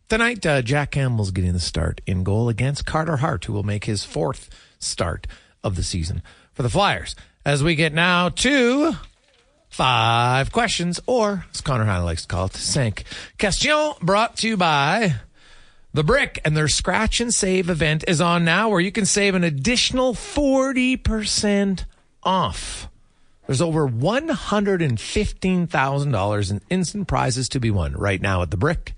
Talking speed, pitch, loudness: 175 wpm, 155 Hz, -21 LUFS